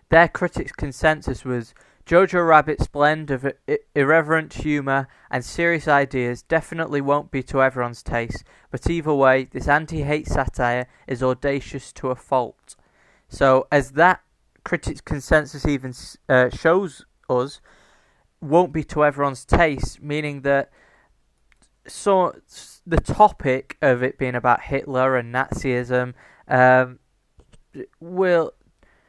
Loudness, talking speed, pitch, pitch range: -21 LUFS, 125 wpm, 140 Hz, 130-155 Hz